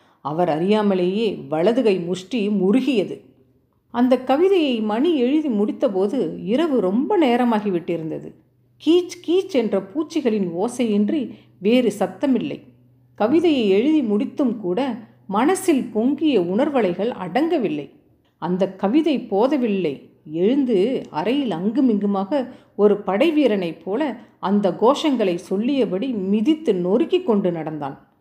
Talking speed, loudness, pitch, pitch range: 95 wpm, -20 LUFS, 225 Hz, 190-280 Hz